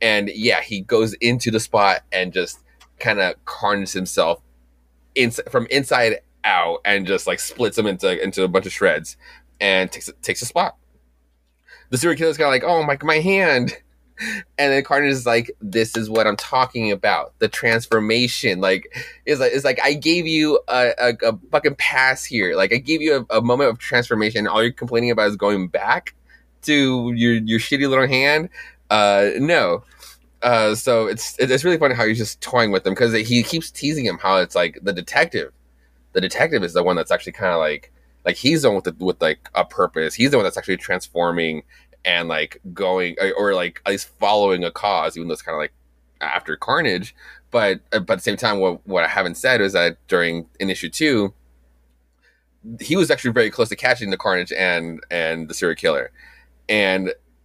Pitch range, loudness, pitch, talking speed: 85-130 Hz, -19 LUFS, 110 Hz, 200 wpm